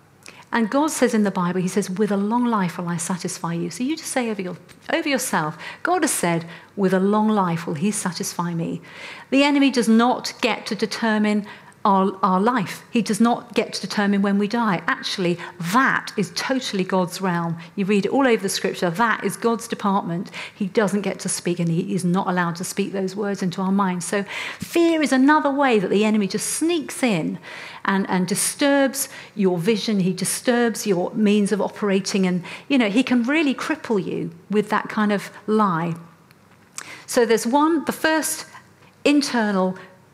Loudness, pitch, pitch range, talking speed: -21 LUFS, 205 Hz, 185-235 Hz, 195 wpm